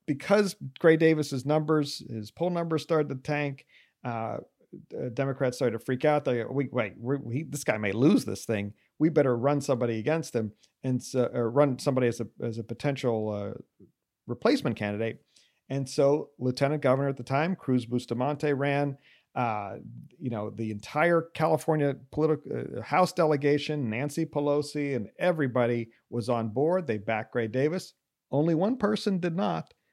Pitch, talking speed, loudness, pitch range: 140 Hz, 165 wpm, -28 LUFS, 120-150 Hz